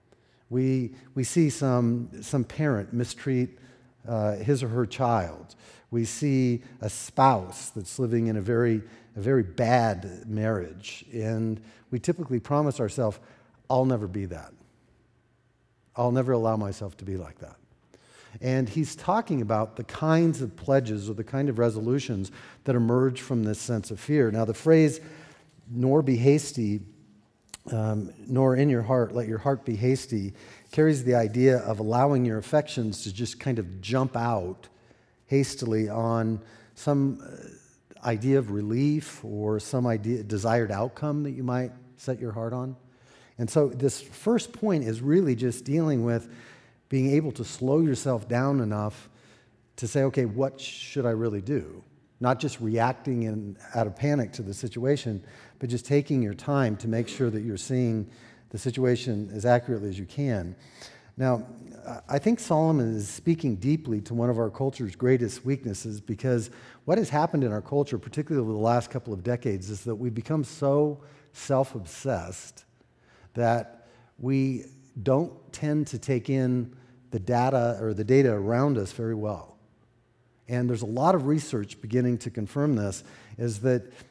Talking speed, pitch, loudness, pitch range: 160 wpm, 120 Hz, -27 LUFS, 110-135 Hz